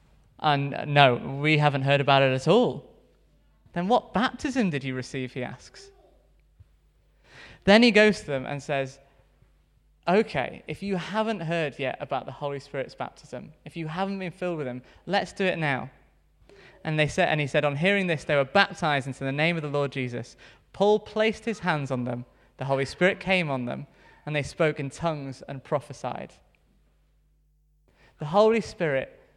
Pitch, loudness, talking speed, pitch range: 150 Hz, -25 LUFS, 180 wpm, 135-185 Hz